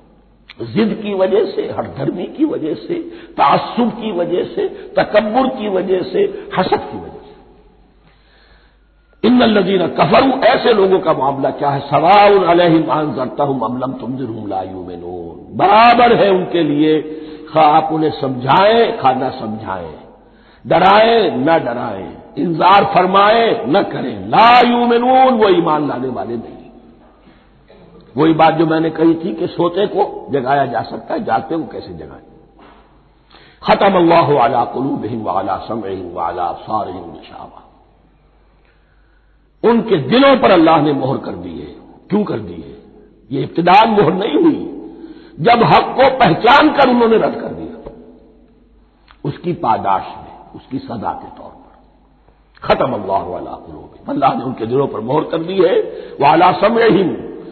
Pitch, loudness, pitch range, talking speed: 190 Hz, -14 LUFS, 150-240 Hz, 145 wpm